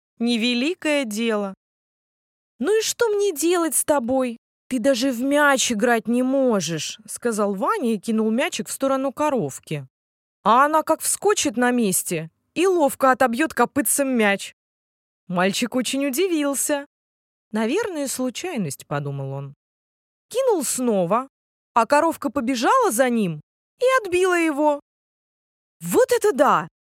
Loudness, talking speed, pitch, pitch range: -21 LUFS, 120 wpm, 260 Hz, 220-300 Hz